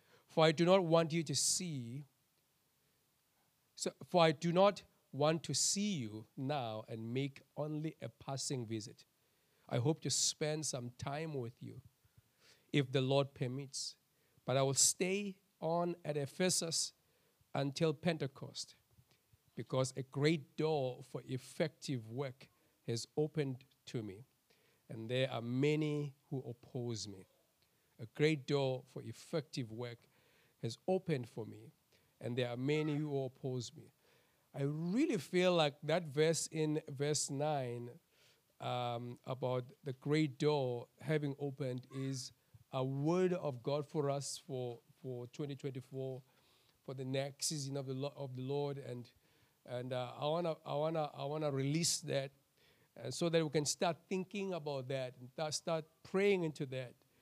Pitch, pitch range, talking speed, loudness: 140 Hz, 130-155 Hz, 150 wpm, -38 LUFS